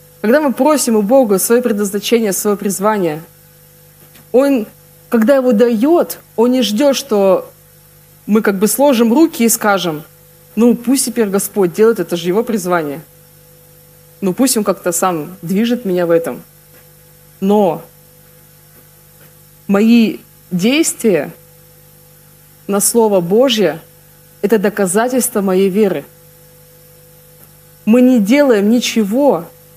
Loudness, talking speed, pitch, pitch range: -13 LUFS, 115 wpm, 190 Hz, 165-230 Hz